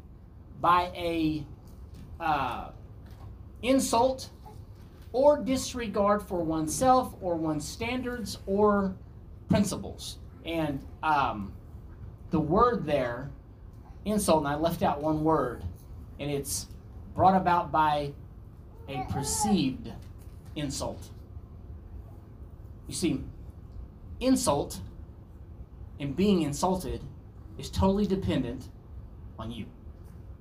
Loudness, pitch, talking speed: -28 LUFS, 110 Hz, 85 wpm